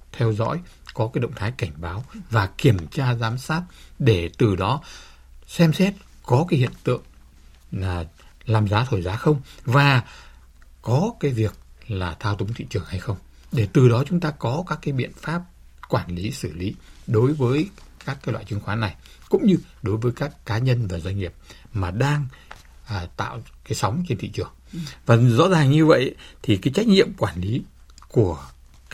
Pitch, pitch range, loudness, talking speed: 115 Hz, 90-140 Hz, -23 LUFS, 190 wpm